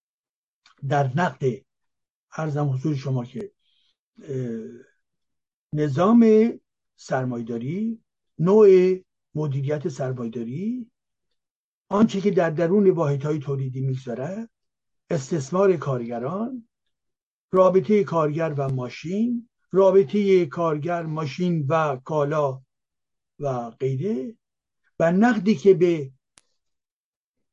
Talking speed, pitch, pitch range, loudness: 75 wpm, 165 Hz, 135-195 Hz, -22 LUFS